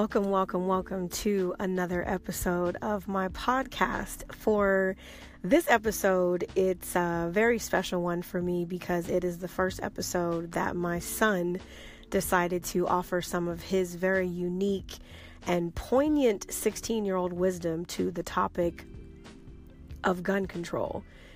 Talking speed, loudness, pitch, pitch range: 135 wpm, -29 LUFS, 185 Hz, 175-195 Hz